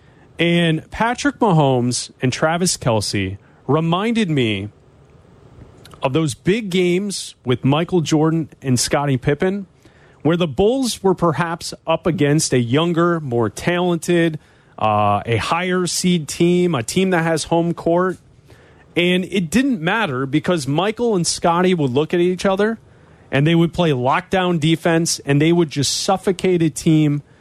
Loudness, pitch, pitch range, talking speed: -18 LUFS, 165 Hz, 140-180 Hz, 145 wpm